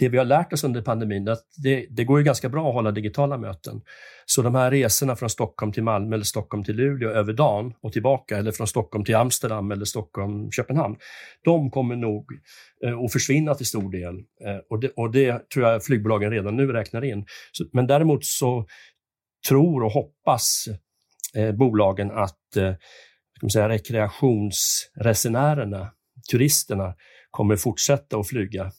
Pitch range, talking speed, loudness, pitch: 105-135 Hz, 165 wpm, -23 LUFS, 115 Hz